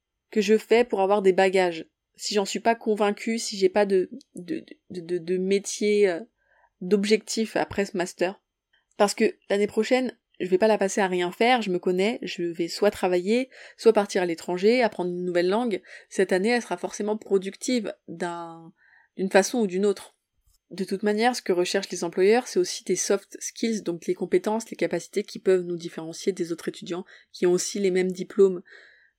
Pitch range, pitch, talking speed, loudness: 180-215 Hz, 195 Hz, 195 wpm, -25 LUFS